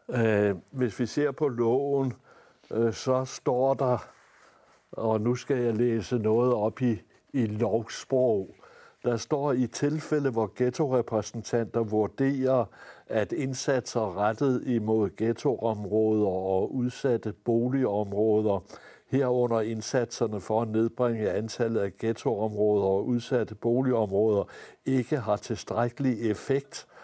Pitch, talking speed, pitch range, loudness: 115 Hz, 105 wpm, 110-130 Hz, -28 LUFS